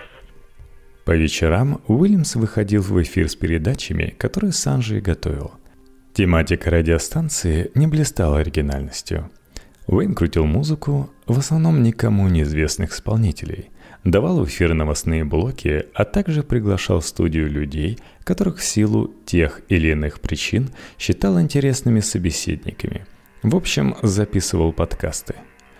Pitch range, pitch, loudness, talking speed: 80-120 Hz, 95 Hz, -20 LUFS, 115 wpm